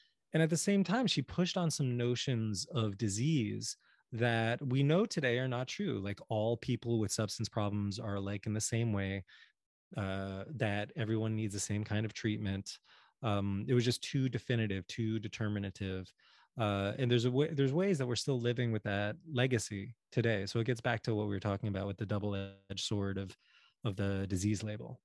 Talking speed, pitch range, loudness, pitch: 195 wpm, 100-125 Hz, -35 LUFS, 110 Hz